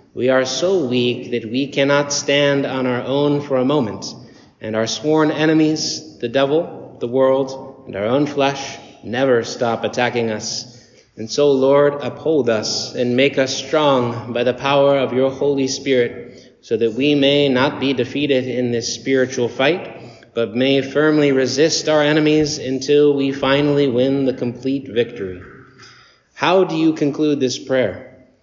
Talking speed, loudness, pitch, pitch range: 160 wpm, -17 LUFS, 135 Hz, 125-145 Hz